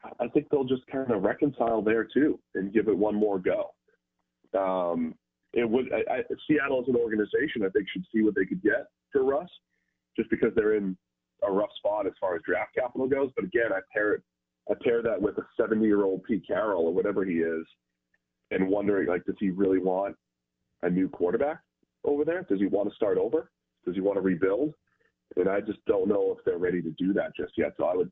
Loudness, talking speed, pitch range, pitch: -28 LUFS, 225 wpm, 90-130 Hz, 100 Hz